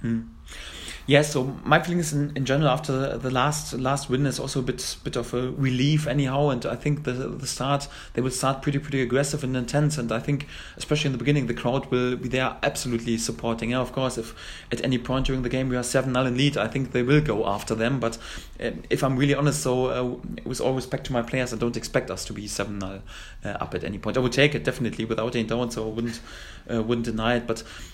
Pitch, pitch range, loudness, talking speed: 125 Hz, 115-140 Hz, -25 LUFS, 250 wpm